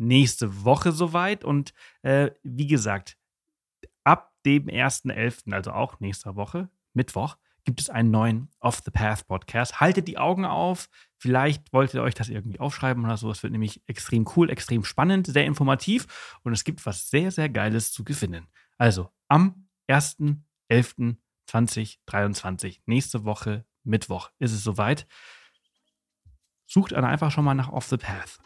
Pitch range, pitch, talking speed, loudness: 110-145 Hz, 125 Hz, 140 wpm, -25 LUFS